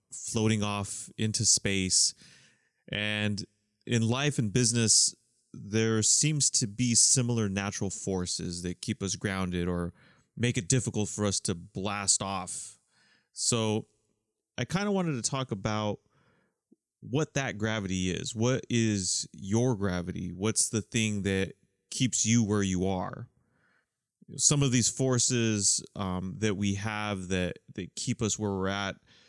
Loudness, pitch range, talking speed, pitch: -28 LUFS, 100-120 Hz, 140 wpm, 110 Hz